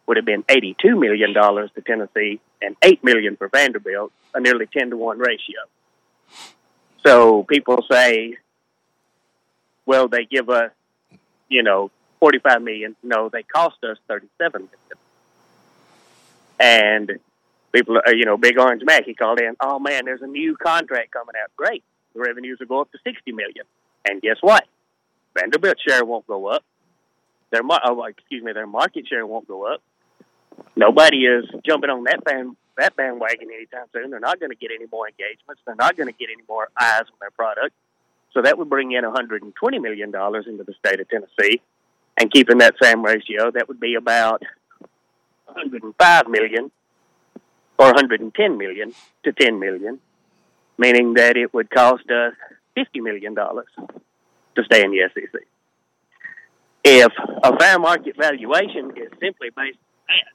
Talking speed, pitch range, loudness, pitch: 160 wpm, 110-135 Hz, -17 LUFS, 120 Hz